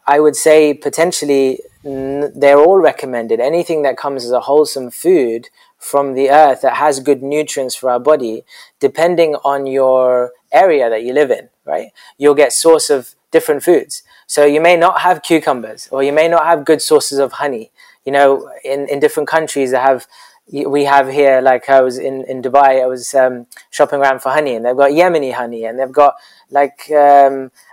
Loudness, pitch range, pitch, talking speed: -13 LUFS, 135-155 Hz, 140 Hz, 195 wpm